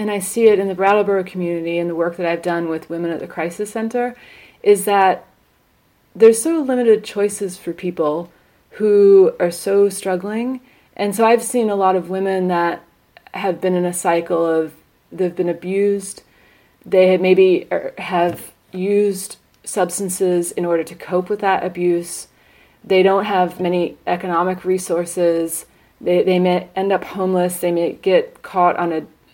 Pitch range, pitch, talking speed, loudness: 175-200 Hz, 185 Hz, 170 wpm, -18 LUFS